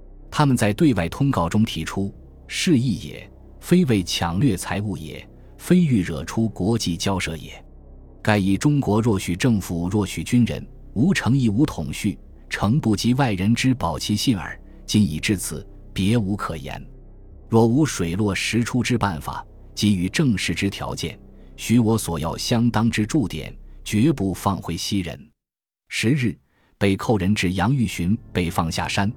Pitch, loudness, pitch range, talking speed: 100 Hz, -22 LUFS, 85-115 Hz, 225 characters per minute